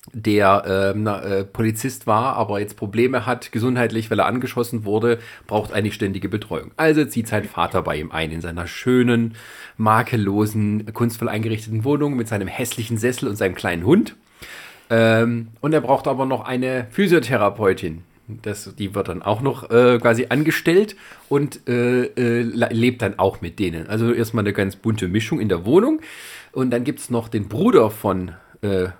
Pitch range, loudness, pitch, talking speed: 105-125 Hz, -20 LUFS, 115 Hz, 175 wpm